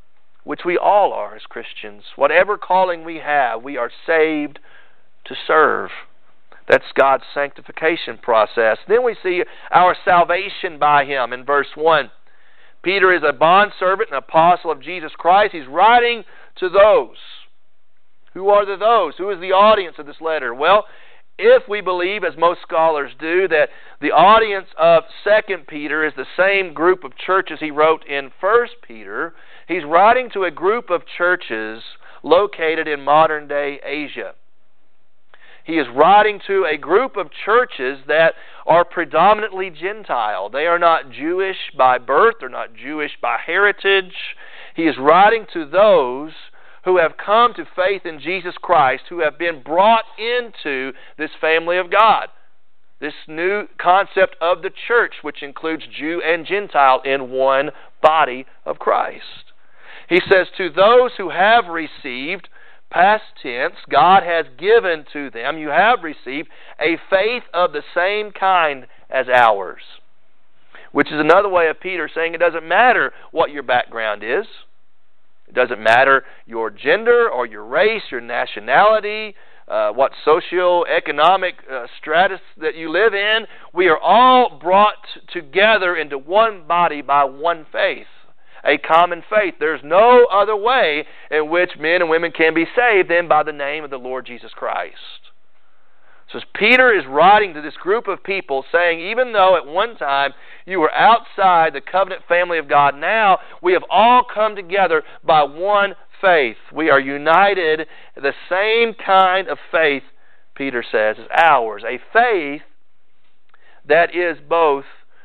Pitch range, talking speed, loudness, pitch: 150-205 Hz, 155 wpm, -16 LUFS, 175 Hz